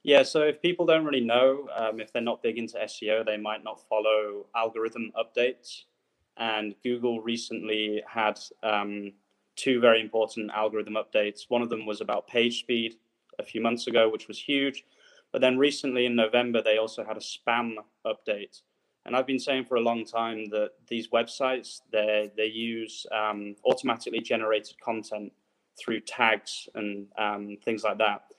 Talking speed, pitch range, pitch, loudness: 165 wpm, 110-120 Hz, 115 Hz, -28 LUFS